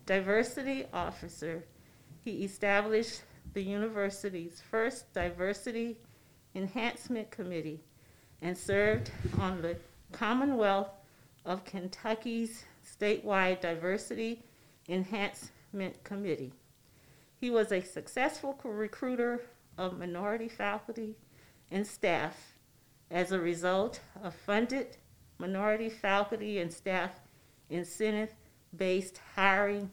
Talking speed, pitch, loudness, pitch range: 85 wpm, 195 Hz, -34 LUFS, 175-220 Hz